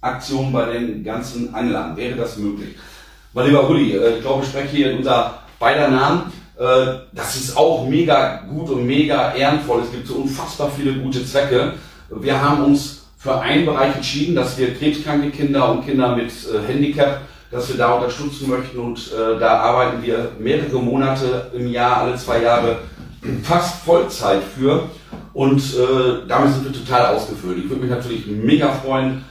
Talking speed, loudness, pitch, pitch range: 165 wpm, -18 LUFS, 130 Hz, 120-140 Hz